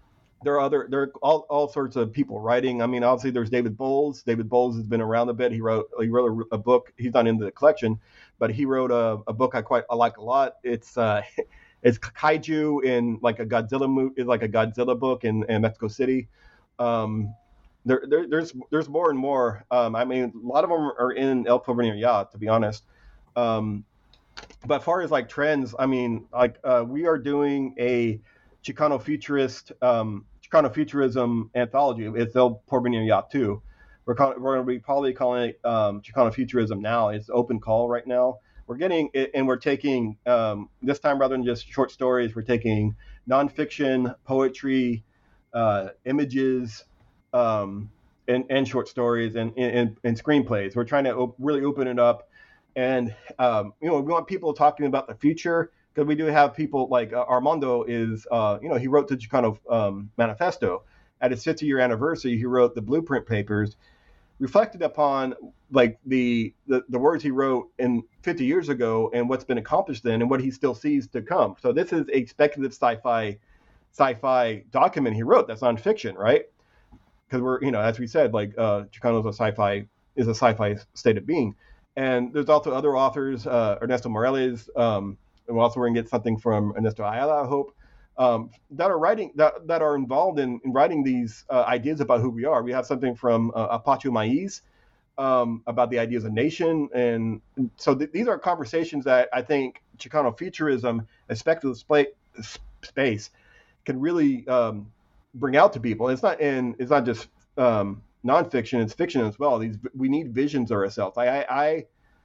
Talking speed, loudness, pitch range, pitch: 195 wpm, -24 LUFS, 115-140 Hz, 125 Hz